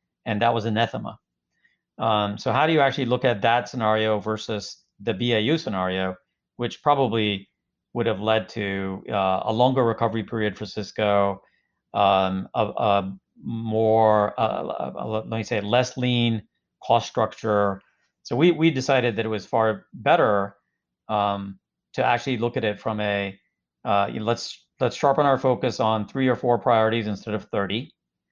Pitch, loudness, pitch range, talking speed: 110 Hz, -23 LUFS, 100-120 Hz, 165 wpm